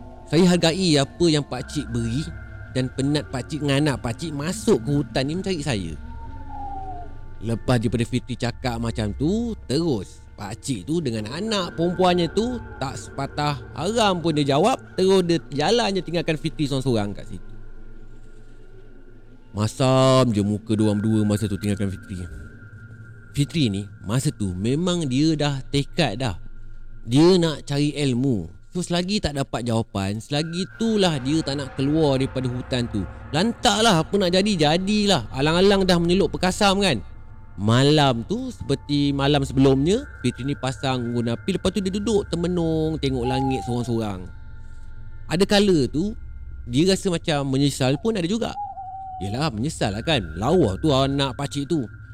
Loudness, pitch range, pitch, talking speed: -22 LUFS, 110-170 Hz, 135 Hz, 155 wpm